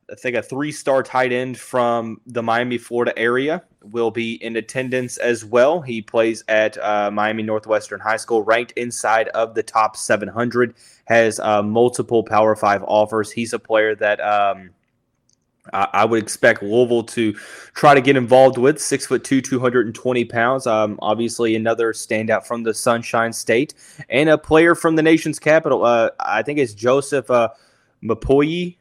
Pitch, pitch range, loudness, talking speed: 115 Hz, 110-130 Hz, -18 LUFS, 170 wpm